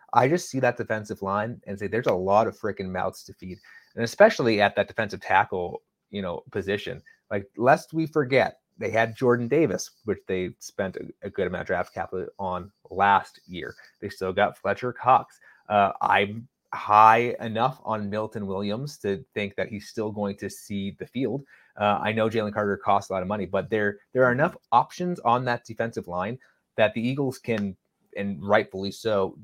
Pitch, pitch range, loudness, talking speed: 110 Hz, 100-120 Hz, -25 LUFS, 195 wpm